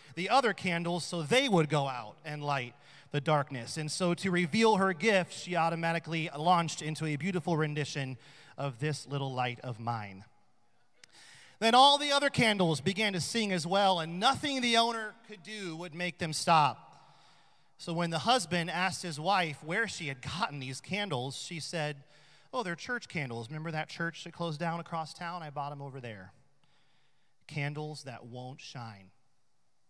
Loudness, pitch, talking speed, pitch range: -31 LUFS, 160 Hz, 175 wpm, 140-180 Hz